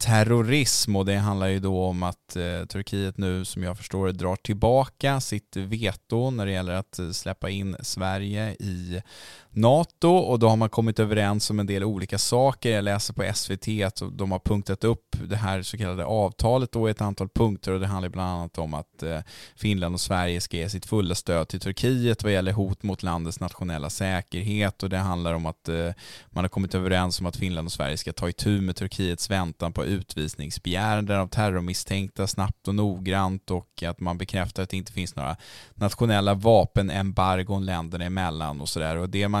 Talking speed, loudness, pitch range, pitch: 190 wpm, -26 LUFS, 90-105 Hz, 95 Hz